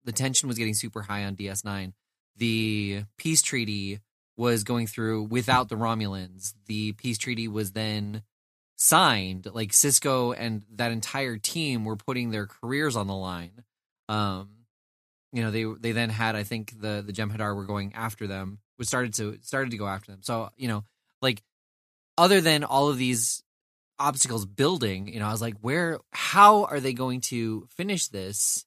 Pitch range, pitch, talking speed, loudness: 105-125 Hz, 110 Hz, 180 wpm, -26 LUFS